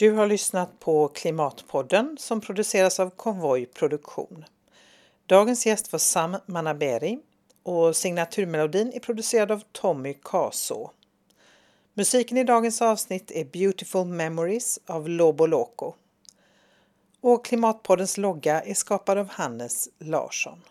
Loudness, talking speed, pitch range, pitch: -24 LUFS, 110 wpm, 165-220 Hz, 195 Hz